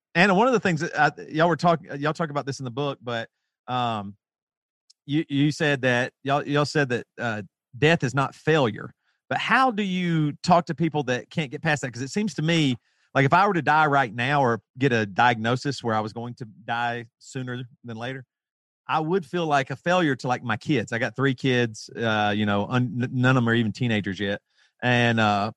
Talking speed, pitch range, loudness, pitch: 230 wpm, 120-155 Hz, -24 LUFS, 135 Hz